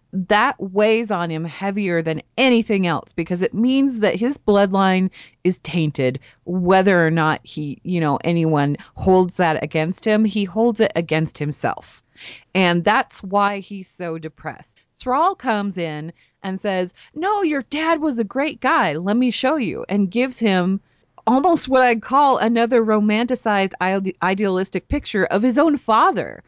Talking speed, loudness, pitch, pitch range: 155 wpm, -19 LUFS, 195 Hz, 170-230 Hz